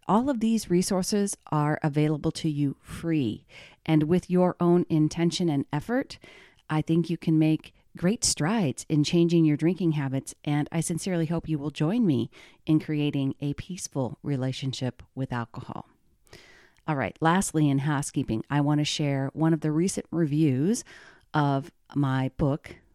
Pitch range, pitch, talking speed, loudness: 140-170 Hz, 155 Hz, 155 wpm, -26 LUFS